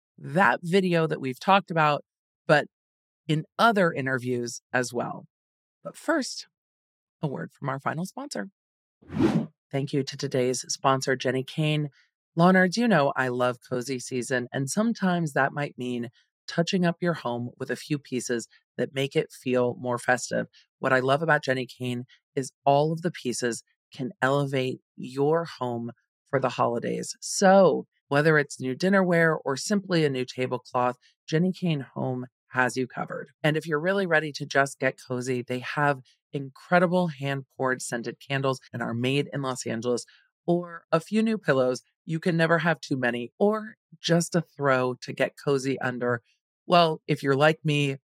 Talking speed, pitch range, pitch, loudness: 165 wpm, 125-165 Hz, 140 Hz, -26 LUFS